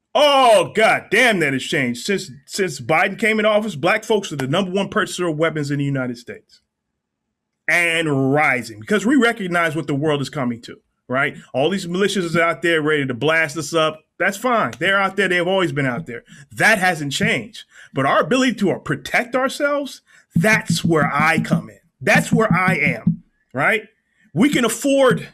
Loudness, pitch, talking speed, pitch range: -18 LUFS, 180 Hz, 190 wpm, 155-215 Hz